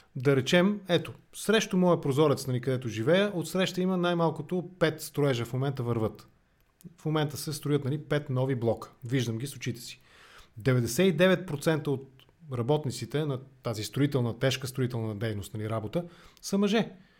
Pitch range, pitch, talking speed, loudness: 125-170 Hz, 140 Hz, 155 wpm, -29 LUFS